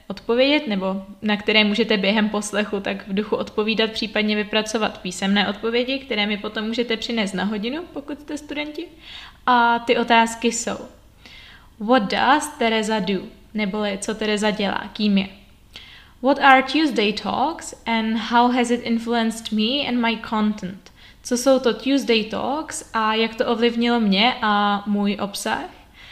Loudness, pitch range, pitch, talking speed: -21 LUFS, 210-240 Hz, 225 Hz, 150 wpm